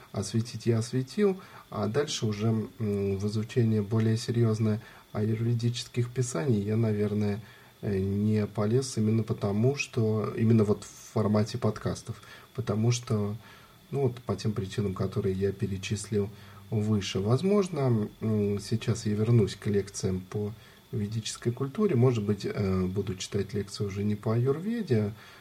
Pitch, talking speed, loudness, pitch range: 110 Hz, 125 wpm, -29 LUFS, 105-120 Hz